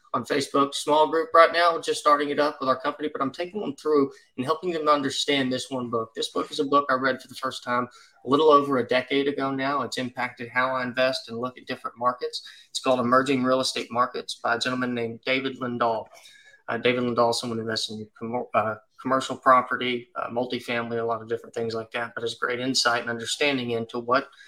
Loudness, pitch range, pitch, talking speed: -25 LUFS, 120-145 Hz, 130 Hz, 225 wpm